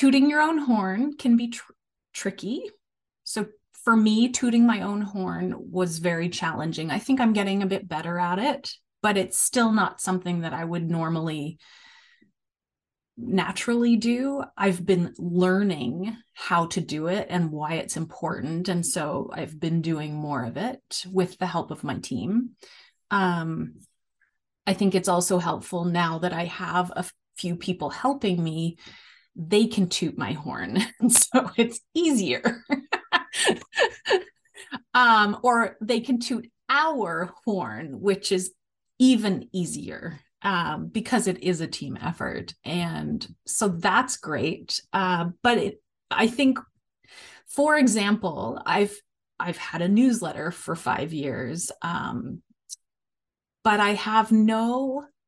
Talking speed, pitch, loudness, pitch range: 140 wpm, 195 Hz, -25 LUFS, 175-235 Hz